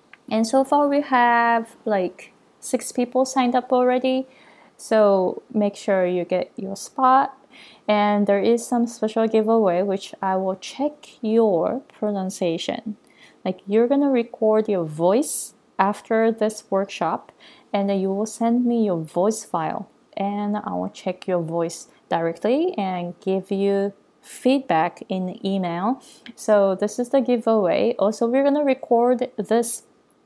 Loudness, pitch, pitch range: -22 LUFS, 215 Hz, 195-245 Hz